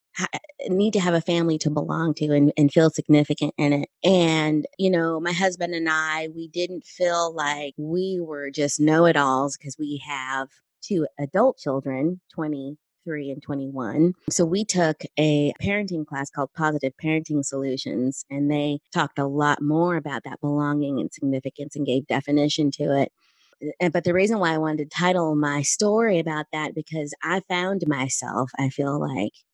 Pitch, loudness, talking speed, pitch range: 150 Hz, -23 LUFS, 175 wpm, 145-170 Hz